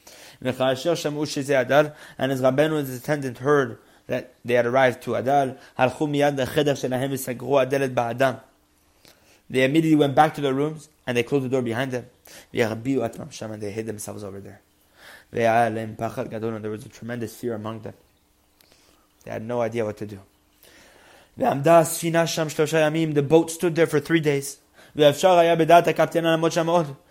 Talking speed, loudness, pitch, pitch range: 120 wpm, -22 LUFS, 135 Hz, 115-155 Hz